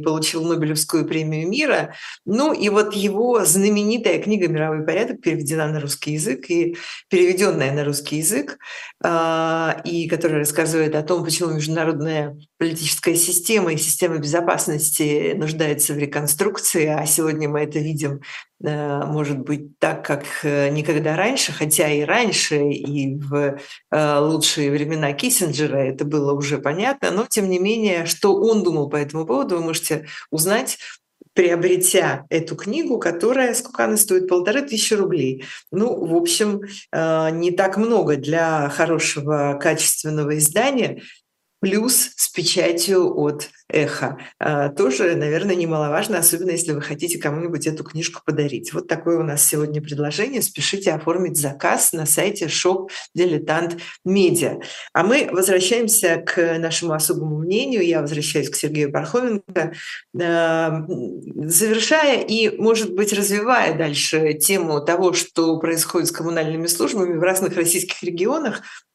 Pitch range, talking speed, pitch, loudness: 150-185 Hz, 130 wpm, 165 Hz, -19 LUFS